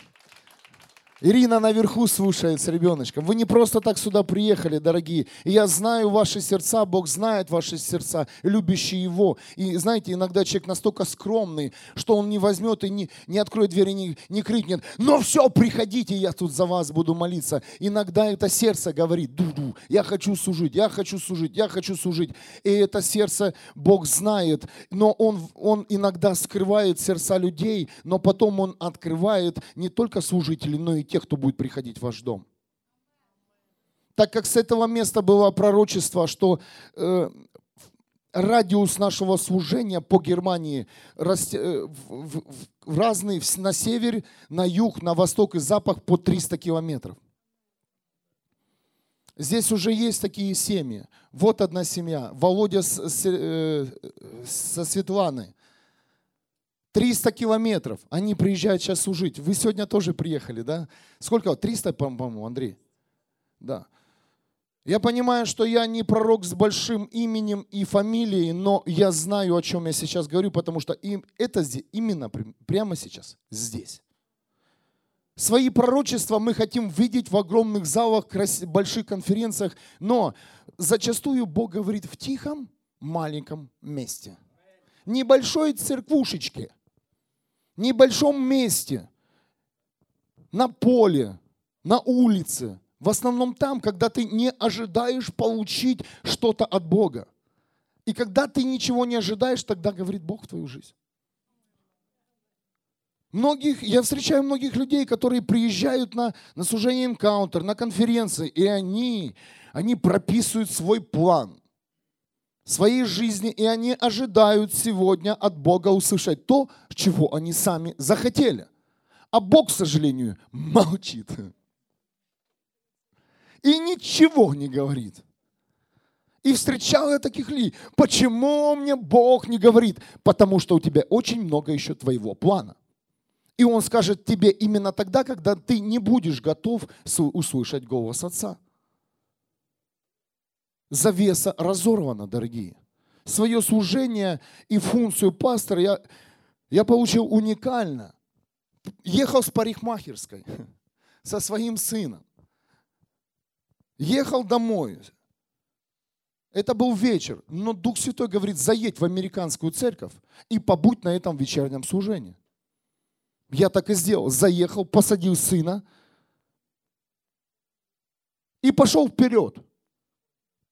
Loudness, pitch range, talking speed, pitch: -23 LUFS, 170-225 Hz, 125 wpm, 200 Hz